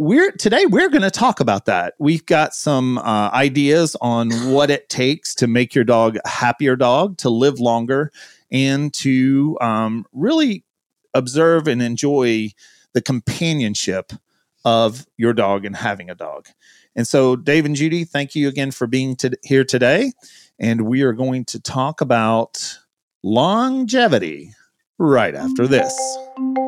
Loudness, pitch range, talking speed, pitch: -17 LUFS, 120-160 Hz, 150 wpm, 135 Hz